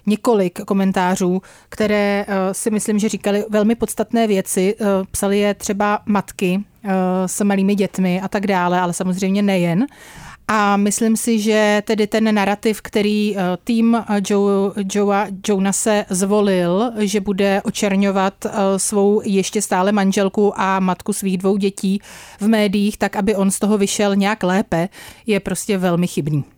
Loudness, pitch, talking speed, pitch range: -18 LUFS, 200 Hz, 150 wpm, 190-210 Hz